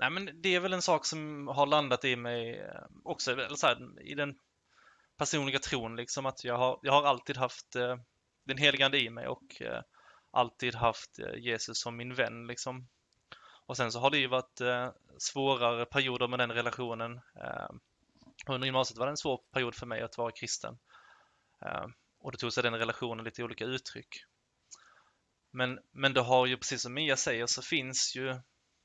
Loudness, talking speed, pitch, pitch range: -32 LUFS, 190 wpm, 125 Hz, 120-135 Hz